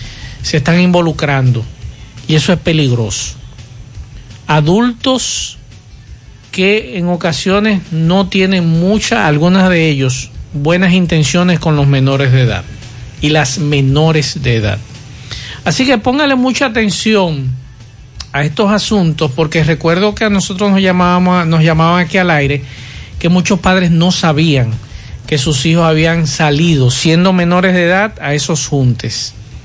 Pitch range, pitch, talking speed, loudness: 130-180 Hz, 160 Hz, 135 wpm, -11 LUFS